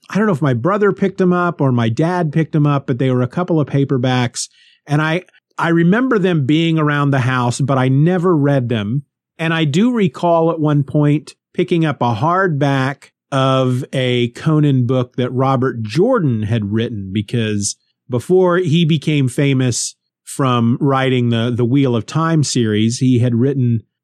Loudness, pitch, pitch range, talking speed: -16 LUFS, 140 Hz, 125-165 Hz, 180 wpm